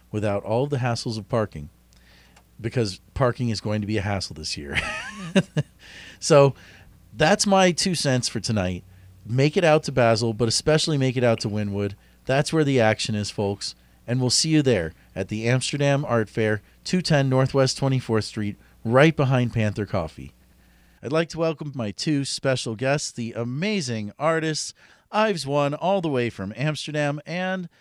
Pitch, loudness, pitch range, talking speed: 120 Hz, -23 LUFS, 105-150 Hz, 170 wpm